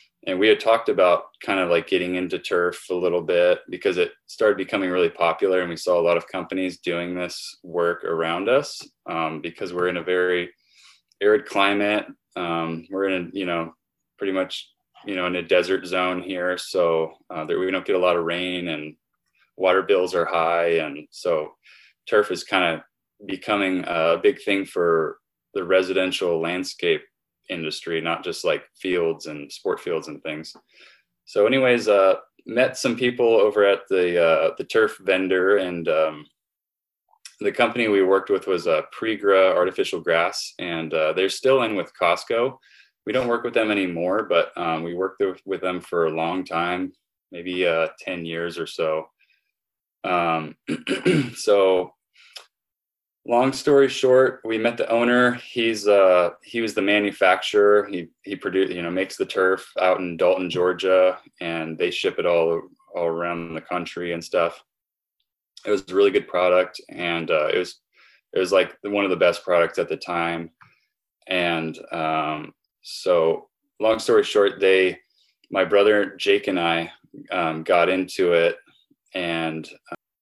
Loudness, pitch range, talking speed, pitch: -22 LUFS, 85-125 Hz, 170 wpm, 95 Hz